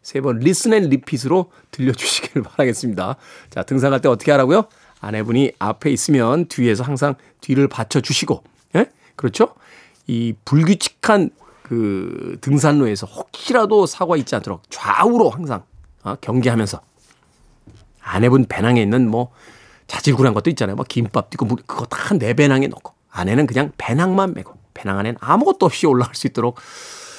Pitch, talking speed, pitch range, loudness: 130 Hz, 340 characters per minute, 115-145 Hz, -18 LUFS